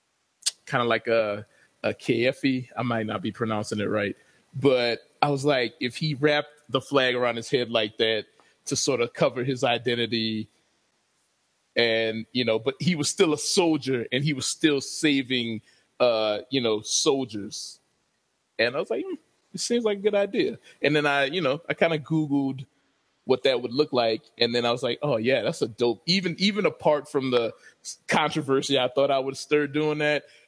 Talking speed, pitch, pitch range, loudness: 195 wpm, 135 Hz, 115-150 Hz, -25 LUFS